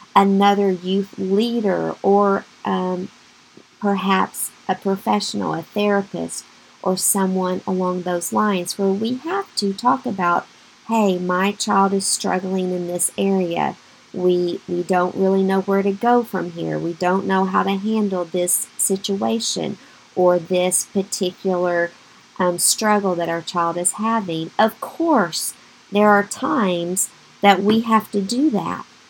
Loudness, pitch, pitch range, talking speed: -20 LUFS, 195 Hz, 180-205 Hz, 140 wpm